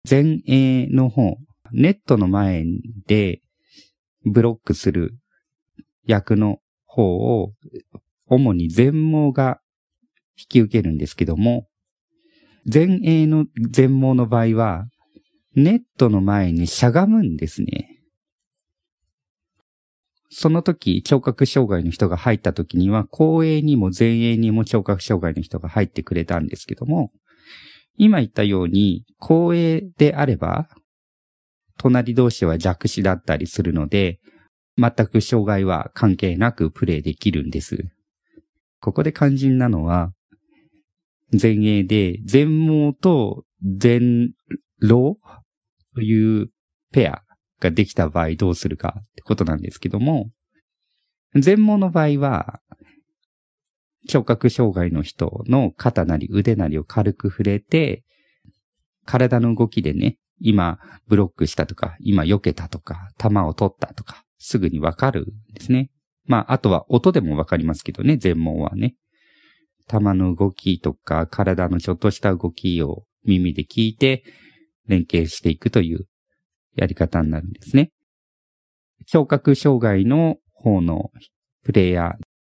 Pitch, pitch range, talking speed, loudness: 110 Hz, 95-135 Hz, 235 characters per minute, -19 LUFS